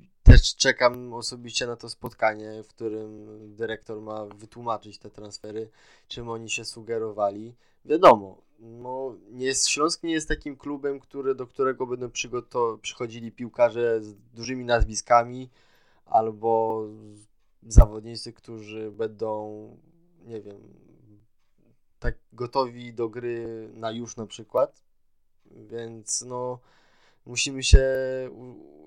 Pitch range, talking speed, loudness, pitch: 110-125 Hz, 115 wpm, -26 LUFS, 115 Hz